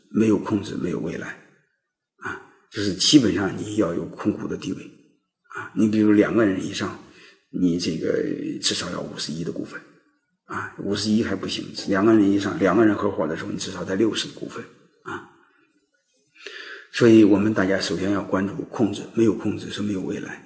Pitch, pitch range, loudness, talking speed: 105 Hz, 95-110 Hz, -22 LUFS, 280 characters per minute